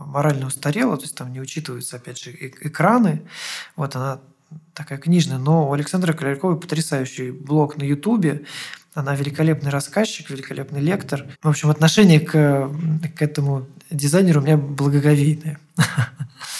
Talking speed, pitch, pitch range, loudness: 135 wpm, 150 Hz, 140-160 Hz, -20 LUFS